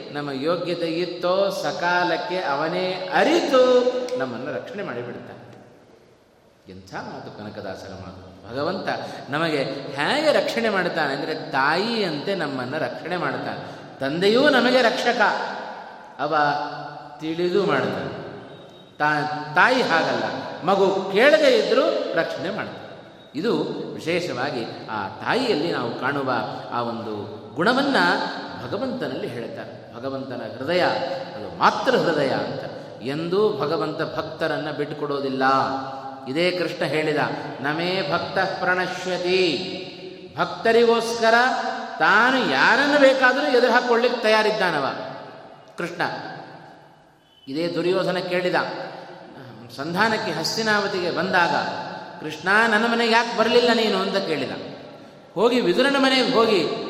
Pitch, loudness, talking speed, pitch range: 175 Hz, -21 LUFS, 95 wpm, 145-220 Hz